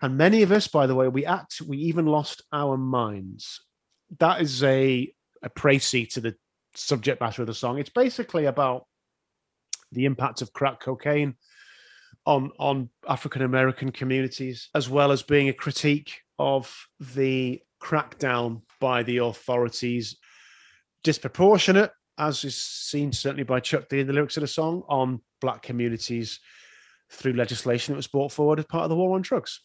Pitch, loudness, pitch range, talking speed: 135 Hz, -25 LUFS, 125-150 Hz, 165 wpm